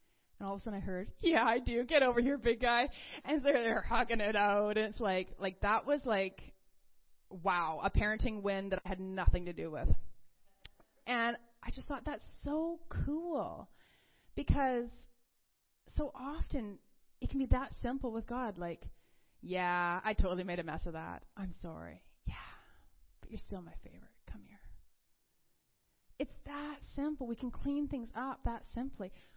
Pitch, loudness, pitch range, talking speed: 230 Hz, -36 LUFS, 195-265 Hz, 170 wpm